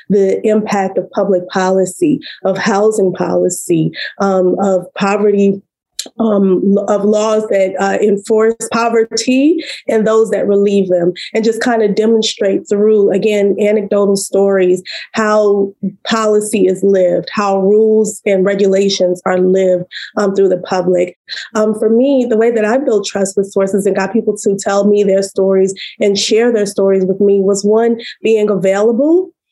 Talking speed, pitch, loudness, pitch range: 150 wpm, 200 Hz, -13 LUFS, 195-220 Hz